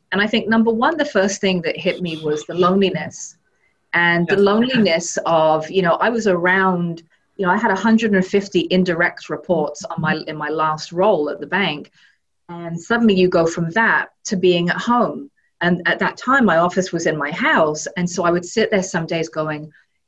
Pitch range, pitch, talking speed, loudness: 170-205 Hz, 180 Hz, 205 wpm, -18 LUFS